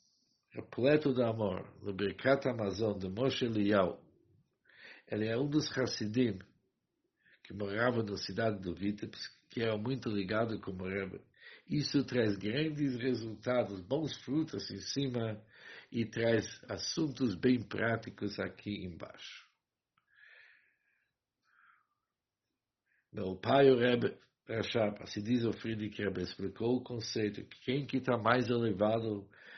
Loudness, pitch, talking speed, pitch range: -34 LUFS, 115 Hz, 120 wpm, 100-125 Hz